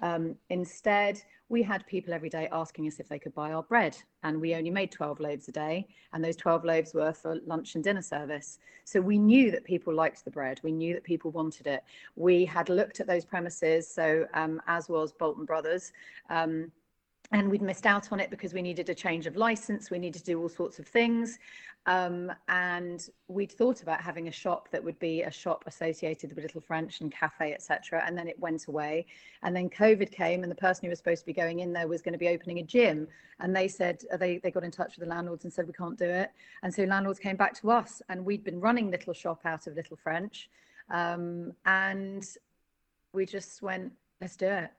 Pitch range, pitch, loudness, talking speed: 160-195 Hz, 175 Hz, -31 LUFS, 230 wpm